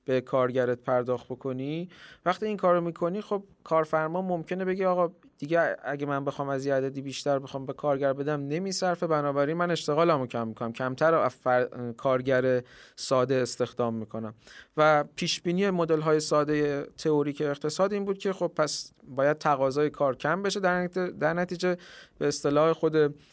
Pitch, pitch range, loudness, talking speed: 150 Hz, 135-175 Hz, -27 LUFS, 160 wpm